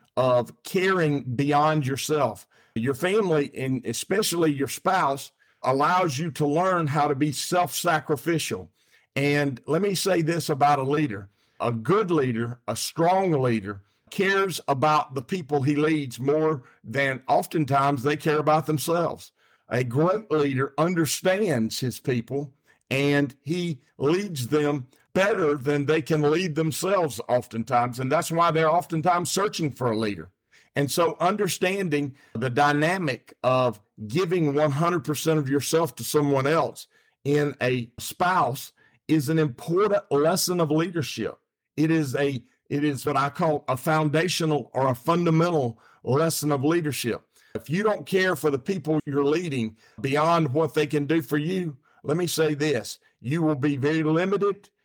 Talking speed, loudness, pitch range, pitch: 150 wpm, -24 LUFS, 135-165 Hz, 150 Hz